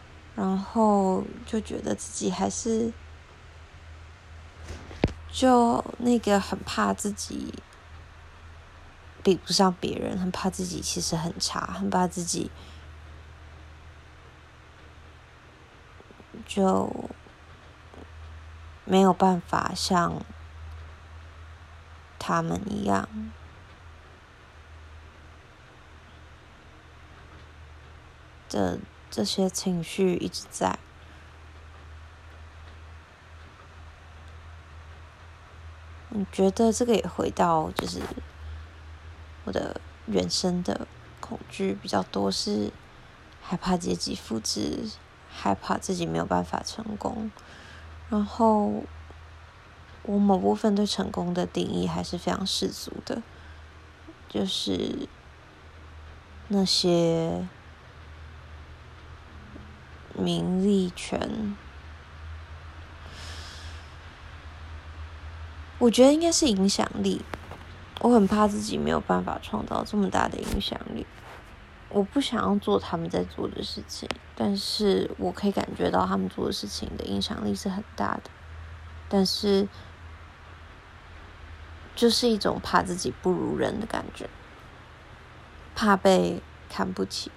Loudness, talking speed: -27 LUFS, 135 characters per minute